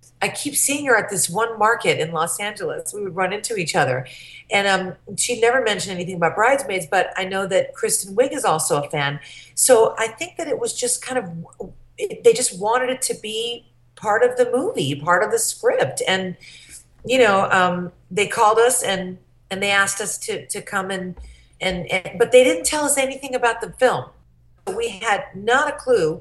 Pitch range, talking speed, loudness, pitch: 185-255 Hz, 205 wpm, -20 LUFS, 210 Hz